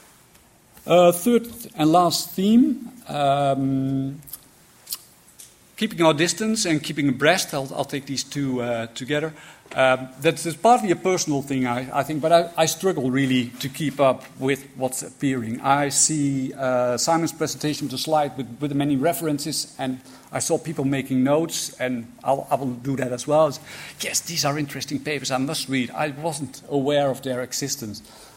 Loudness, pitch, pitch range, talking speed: -22 LUFS, 140 Hz, 130-160 Hz, 170 wpm